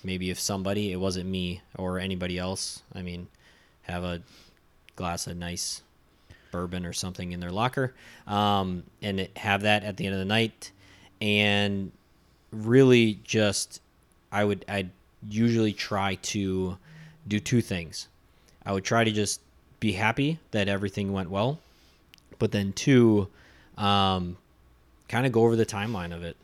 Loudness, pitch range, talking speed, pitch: -27 LUFS, 90-105 Hz, 150 wpm, 100 Hz